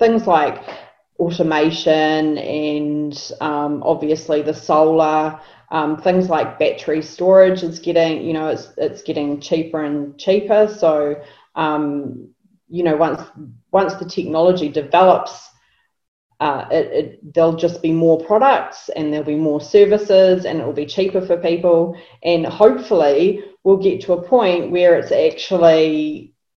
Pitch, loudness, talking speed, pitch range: 165 Hz, -17 LUFS, 140 wpm, 155-185 Hz